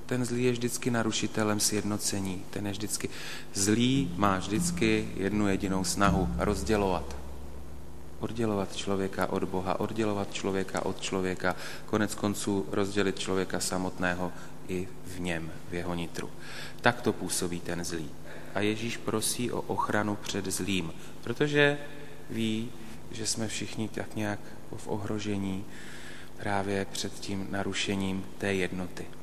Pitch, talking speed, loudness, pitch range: 100 Hz, 125 wpm, -31 LUFS, 90-110 Hz